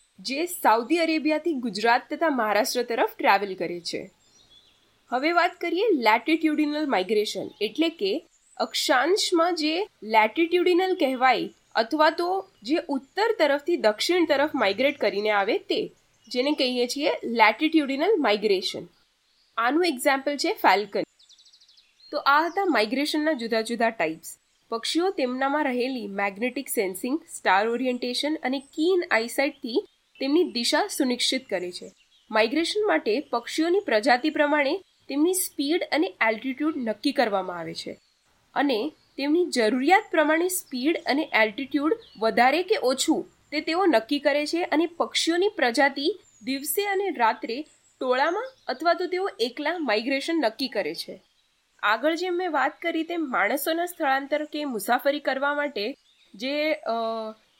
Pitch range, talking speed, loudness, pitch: 240-335 Hz, 125 wpm, -24 LUFS, 290 Hz